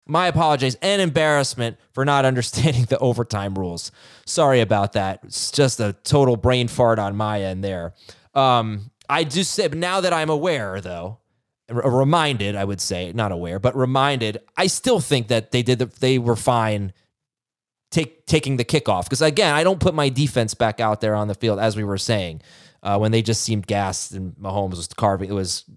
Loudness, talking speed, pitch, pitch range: -20 LUFS, 195 wpm, 120 Hz, 100-140 Hz